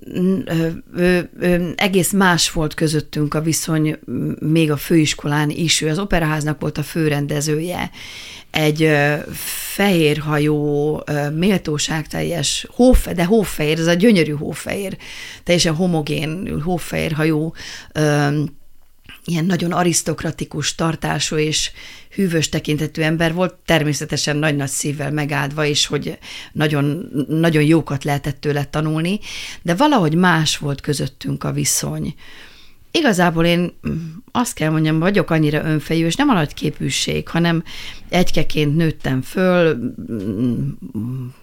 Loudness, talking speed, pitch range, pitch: -18 LUFS, 110 wpm, 150-170 Hz, 155 Hz